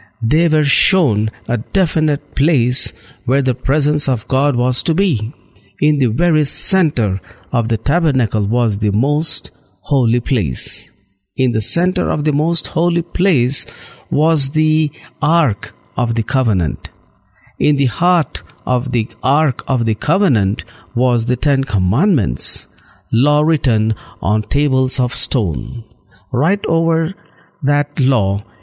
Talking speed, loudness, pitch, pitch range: 130 wpm, -16 LUFS, 130 Hz, 110-150 Hz